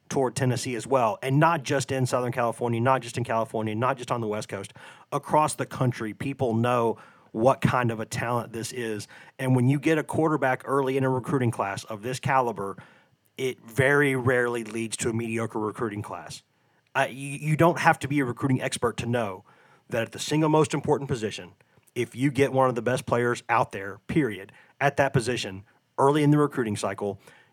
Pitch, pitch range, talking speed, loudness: 125 Hz, 115-140 Hz, 205 wpm, -26 LUFS